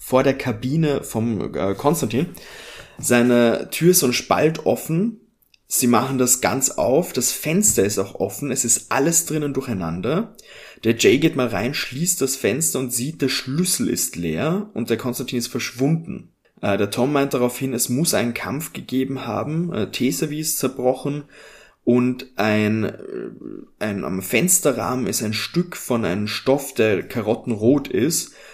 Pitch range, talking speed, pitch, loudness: 120-150 Hz, 160 wpm, 130 Hz, -20 LUFS